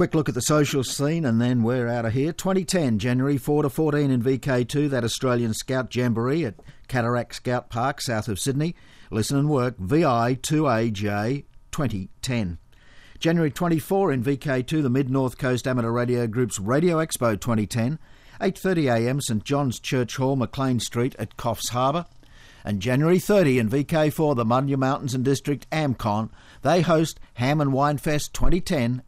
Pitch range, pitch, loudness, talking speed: 120-150 Hz, 130 Hz, -24 LUFS, 155 wpm